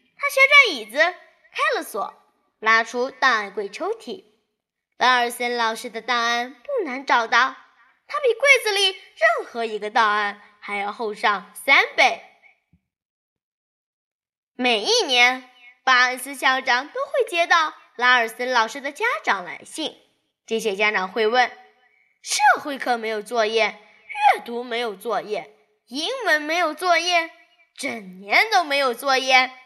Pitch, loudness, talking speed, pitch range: 255 Hz, -20 LUFS, 200 characters per minute, 230-330 Hz